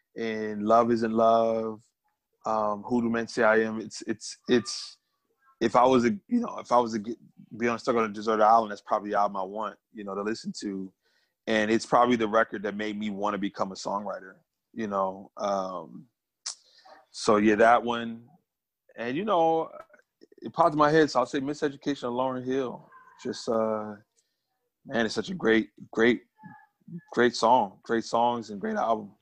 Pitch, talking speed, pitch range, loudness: 115 Hz, 185 wpm, 110-145 Hz, -27 LUFS